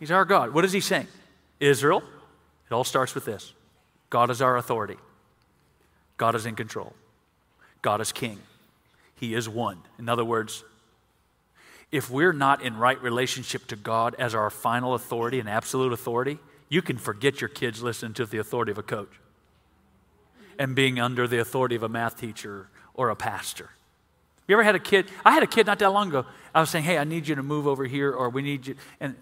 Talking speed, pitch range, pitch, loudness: 200 wpm, 115-140 Hz, 125 Hz, -25 LUFS